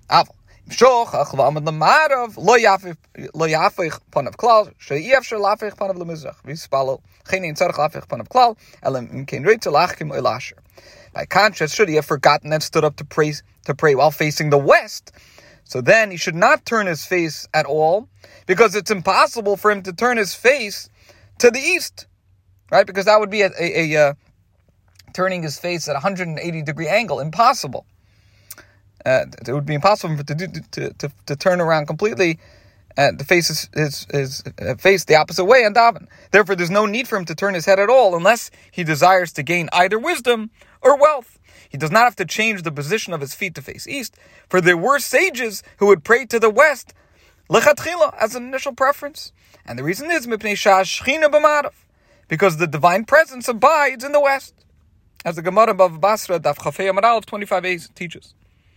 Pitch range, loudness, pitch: 150-220 Hz, -17 LUFS, 185 Hz